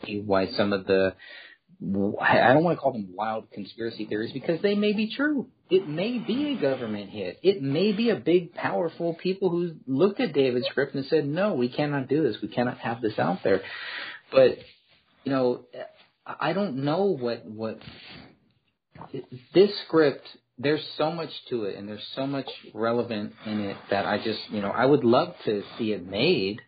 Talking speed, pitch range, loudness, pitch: 185 wpm, 110-175 Hz, -26 LUFS, 135 Hz